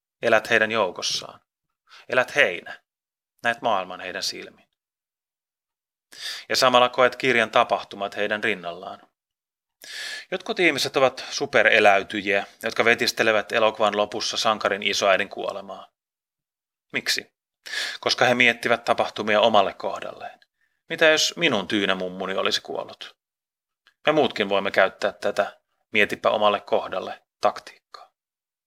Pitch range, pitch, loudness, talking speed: 100-120 Hz, 110 Hz, -22 LUFS, 105 wpm